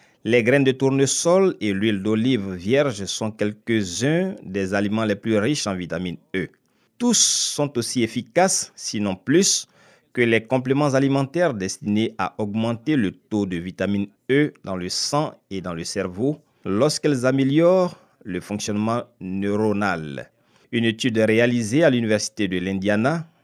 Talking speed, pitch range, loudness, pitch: 140 wpm, 100-140 Hz, -21 LUFS, 115 Hz